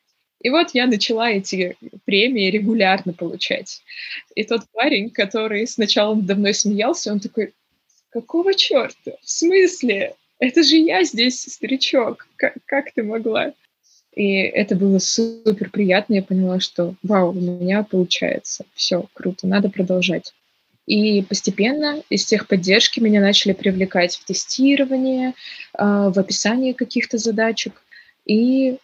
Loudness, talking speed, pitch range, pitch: -18 LUFS, 125 wpm, 195-255 Hz, 215 Hz